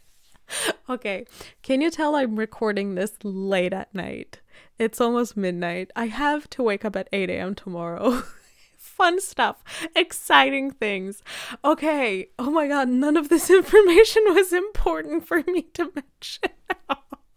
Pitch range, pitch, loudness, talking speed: 205-335 Hz, 265 Hz, -22 LUFS, 140 wpm